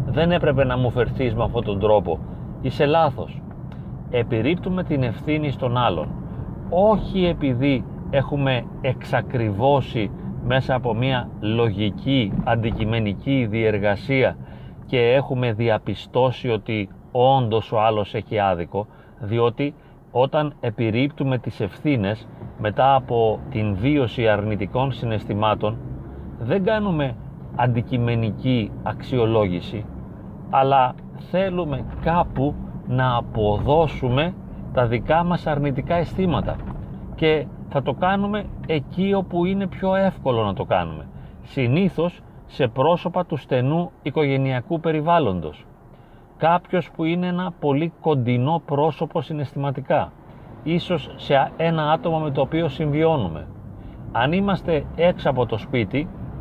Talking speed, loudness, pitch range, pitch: 105 wpm, -22 LUFS, 115-155 Hz, 130 Hz